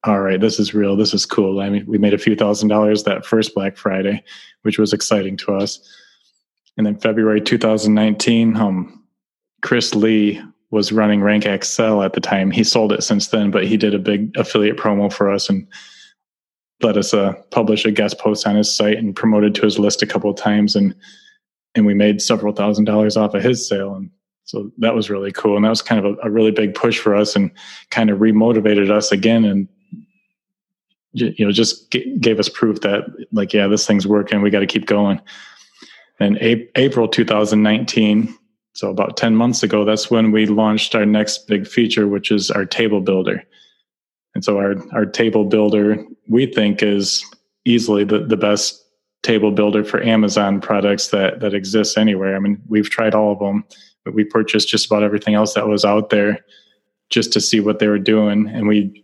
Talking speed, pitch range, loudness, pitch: 200 wpm, 105-110 Hz, -16 LUFS, 105 Hz